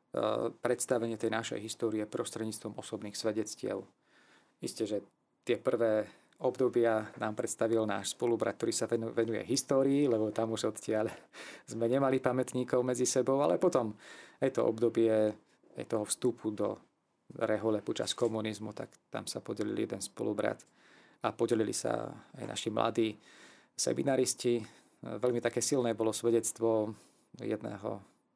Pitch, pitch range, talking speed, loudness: 115 Hz, 110-125 Hz, 125 wpm, -33 LUFS